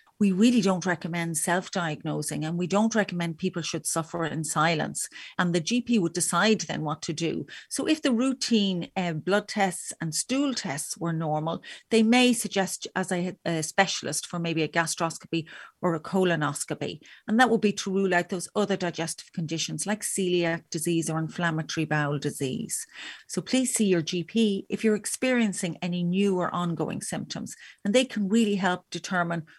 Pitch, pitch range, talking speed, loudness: 180 Hz, 165-205 Hz, 175 wpm, -27 LUFS